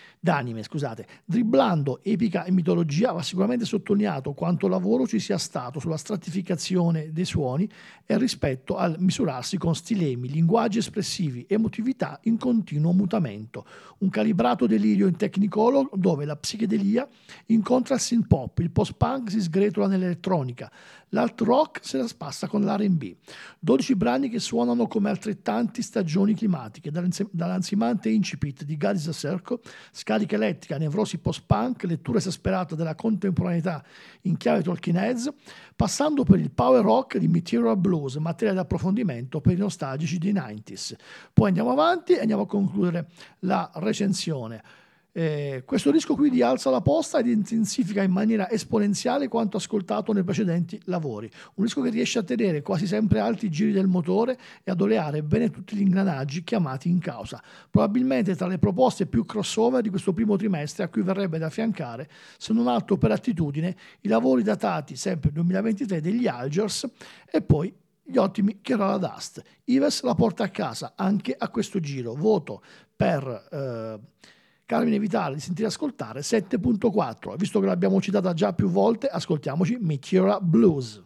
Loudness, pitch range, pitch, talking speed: -25 LUFS, 165-220 Hz, 195 Hz, 155 wpm